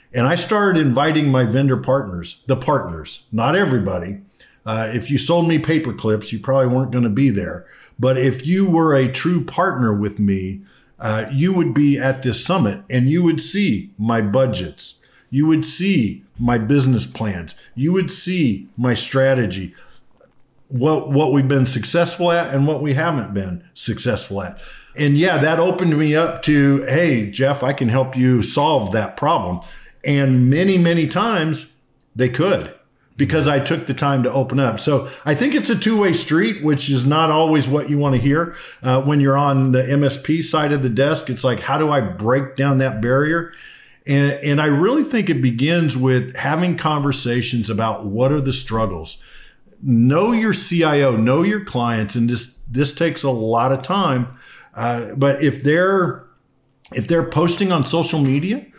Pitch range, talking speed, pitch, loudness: 125-160 Hz, 180 wpm, 140 Hz, -18 LUFS